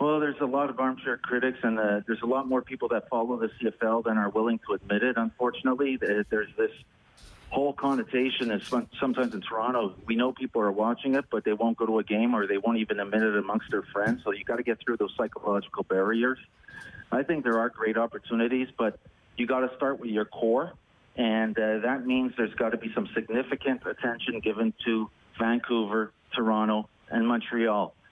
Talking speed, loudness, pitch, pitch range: 205 wpm, -28 LUFS, 115 Hz, 110-130 Hz